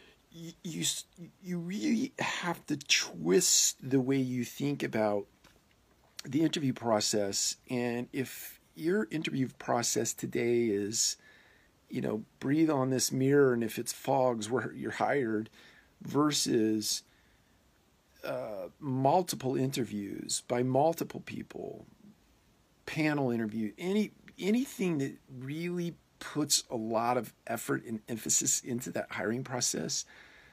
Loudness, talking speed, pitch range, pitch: -31 LUFS, 115 wpm, 115-160 Hz, 130 Hz